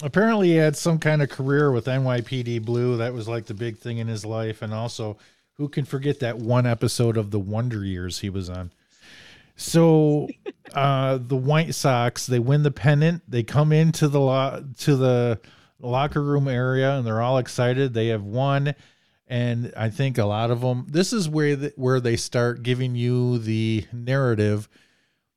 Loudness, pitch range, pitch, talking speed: -23 LUFS, 115-145 Hz, 125 Hz, 185 wpm